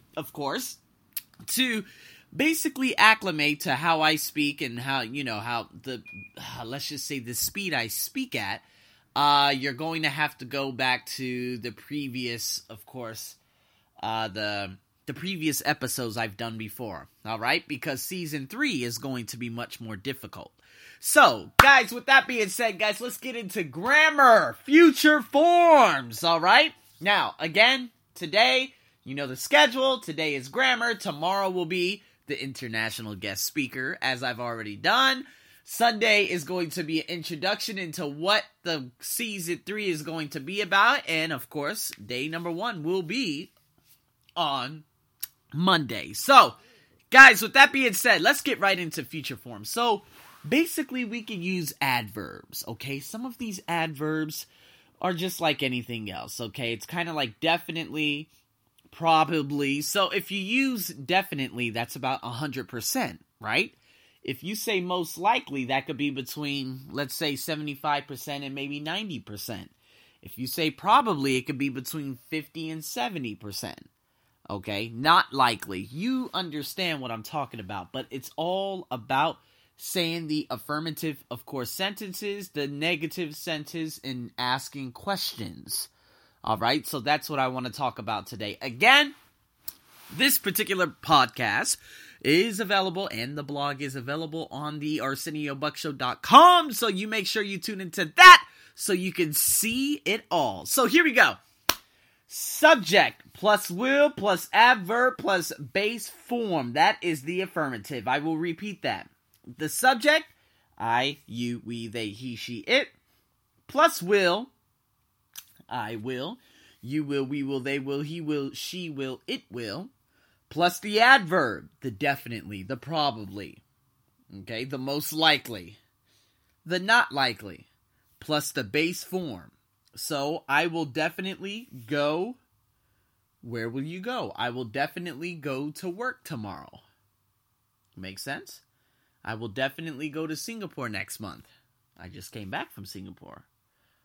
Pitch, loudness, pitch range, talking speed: 150 Hz, -24 LUFS, 125-190 Hz, 145 wpm